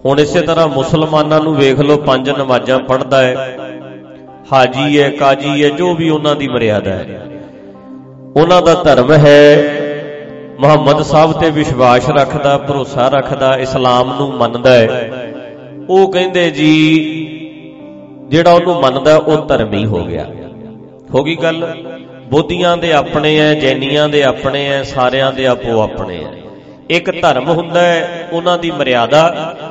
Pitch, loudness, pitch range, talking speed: 145 Hz, -11 LUFS, 130-155 Hz, 140 wpm